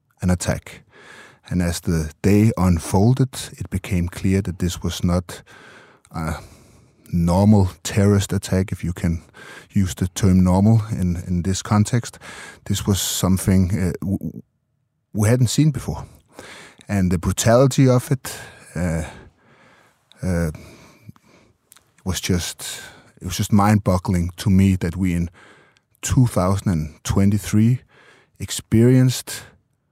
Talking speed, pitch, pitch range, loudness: 115 wpm, 95 Hz, 90-110 Hz, -20 LUFS